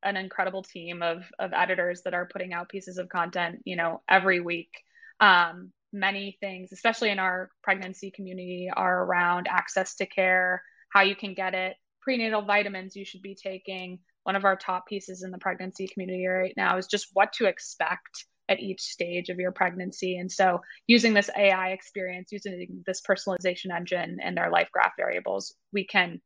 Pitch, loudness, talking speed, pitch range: 185 Hz, -27 LUFS, 185 wpm, 180-195 Hz